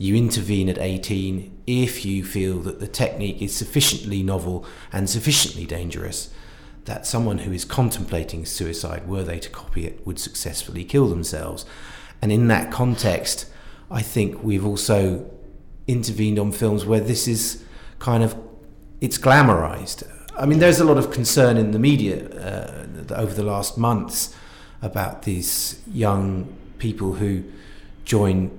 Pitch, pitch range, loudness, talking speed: 100 Hz, 95-115 Hz, -22 LUFS, 145 wpm